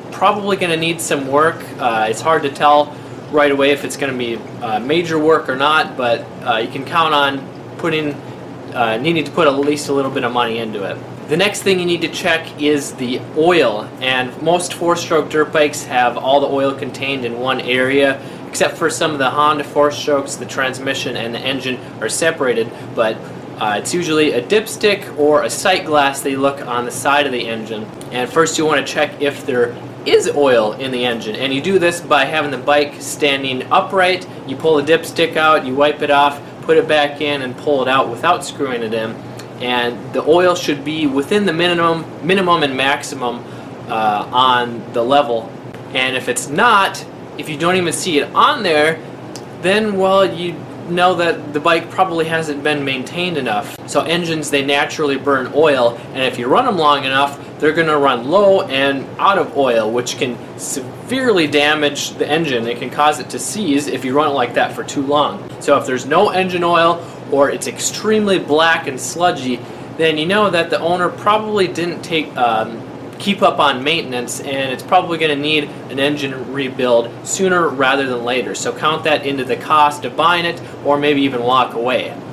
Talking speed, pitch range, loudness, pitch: 205 wpm, 130-165 Hz, -16 LUFS, 145 Hz